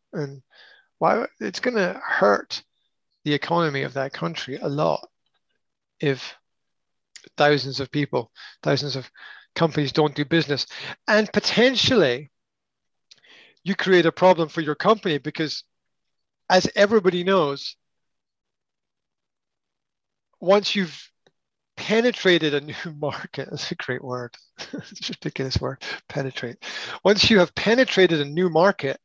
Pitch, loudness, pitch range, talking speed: 160 Hz, -22 LUFS, 140-185 Hz, 115 wpm